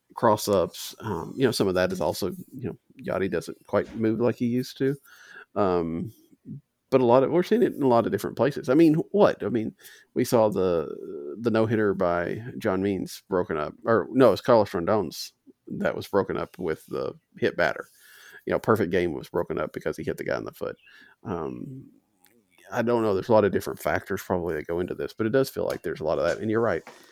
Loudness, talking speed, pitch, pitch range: -25 LUFS, 235 wpm, 120 Hz, 95-135 Hz